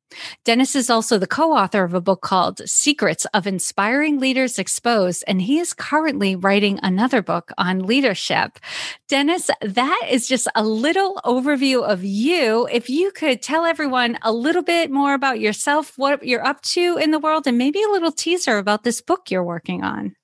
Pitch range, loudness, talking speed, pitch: 210-305 Hz, -19 LUFS, 185 wpm, 255 Hz